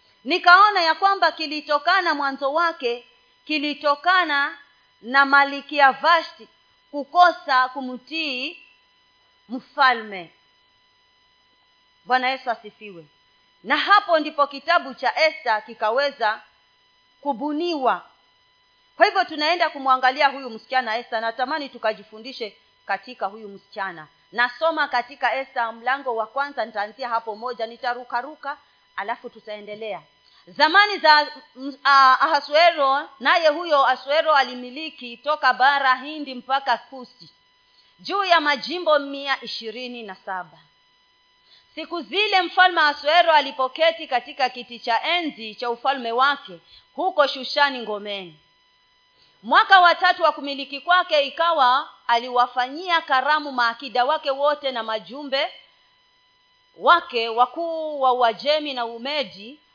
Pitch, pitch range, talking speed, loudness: 275 Hz, 240-320 Hz, 105 wpm, -20 LUFS